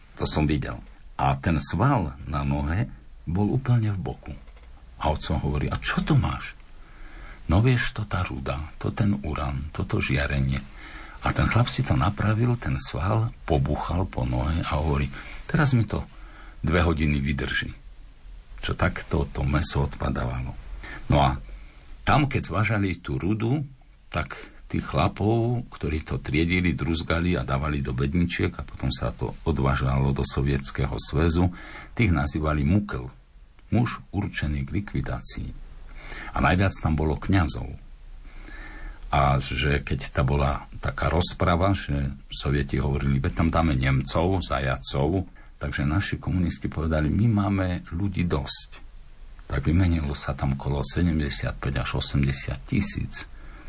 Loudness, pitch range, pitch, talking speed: -25 LUFS, 70-95 Hz, 75 Hz, 135 wpm